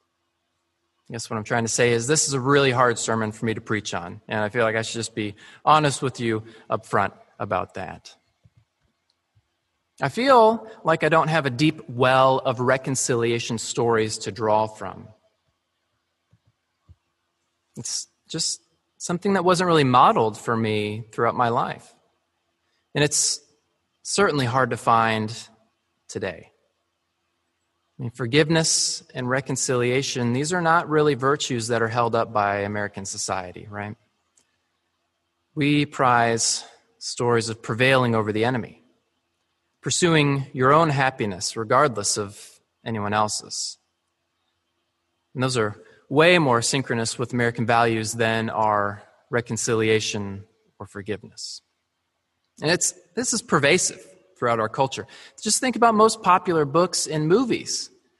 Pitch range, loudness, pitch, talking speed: 100-140 Hz, -22 LUFS, 115 Hz, 135 wpm